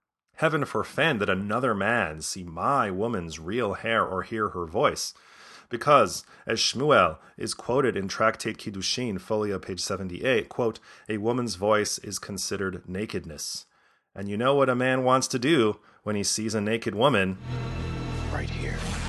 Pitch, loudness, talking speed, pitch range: 105 Hz, -26 LUFS, 155 wpm, 95-120 Hz